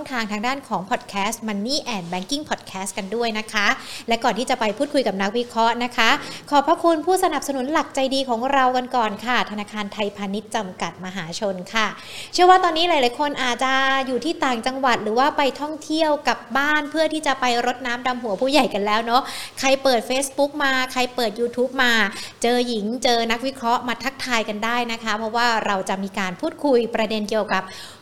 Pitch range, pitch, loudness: 215-270 Hz, 245 Hz, -21 LUFS